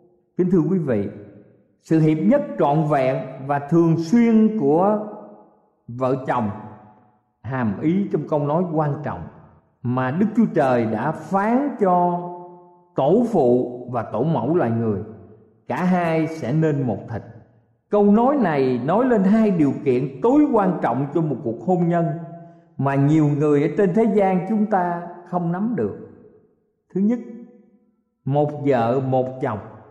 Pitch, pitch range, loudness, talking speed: 160 Hz, 125-190 Hz, -20 LUFS, 150 wpm